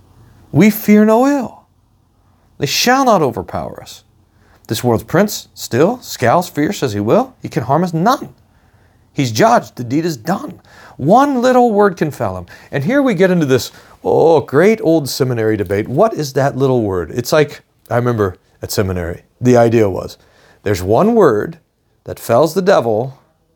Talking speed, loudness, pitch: 170 wpm, -14 LUFS, 130 Hz